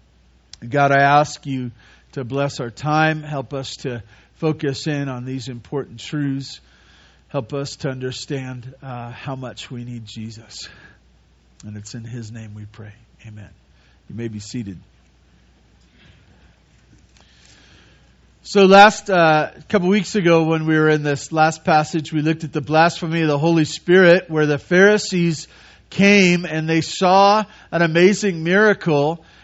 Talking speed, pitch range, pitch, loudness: 145 wpm, 120-165 Hz, 140 Hz, -17 LUFS